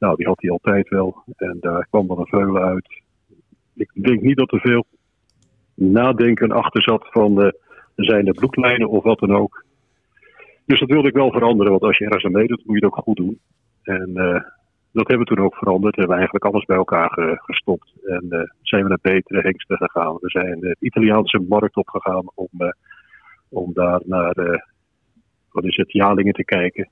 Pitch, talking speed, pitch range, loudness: 100 Hz, 195 wpm, 90-110 Hz, -18 LUFS